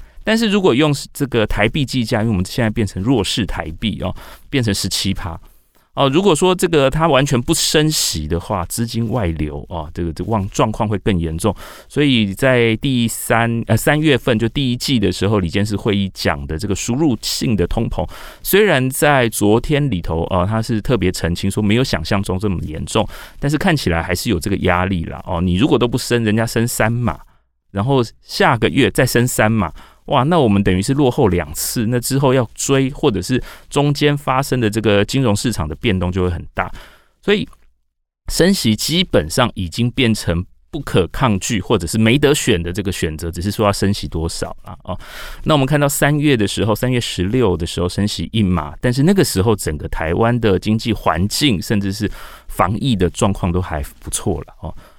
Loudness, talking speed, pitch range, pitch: -17 LUFS, 295 characters per minute, 90-130 Hz, 110 Hz